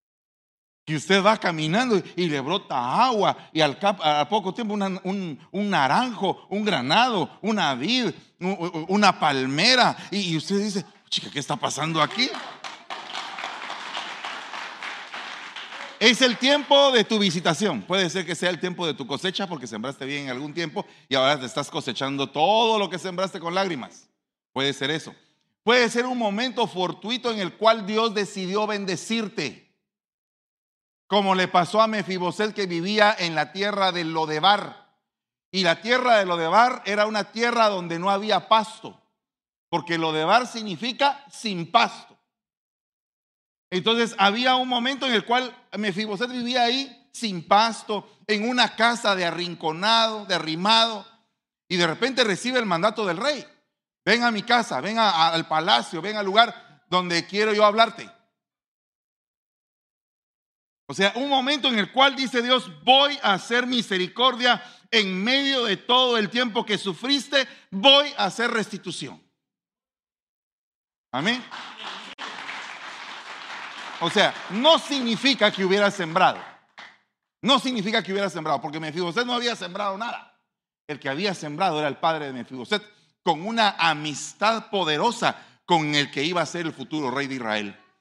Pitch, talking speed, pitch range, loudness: 200 Hz, 150 wpm, 170-230 Hz, -22 LUFS